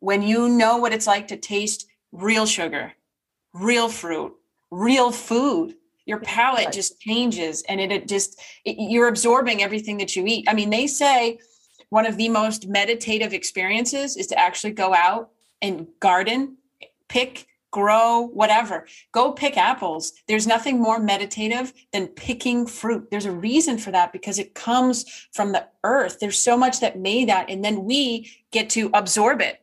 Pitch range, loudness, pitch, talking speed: 200-240 Hz, -21 LUFS, 220 Hz, 170 wpm